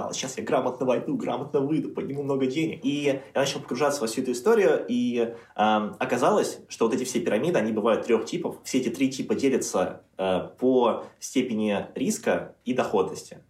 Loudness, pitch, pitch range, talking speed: -26 LUFS, 130 Hz, 110-140 Hz, 180 wpm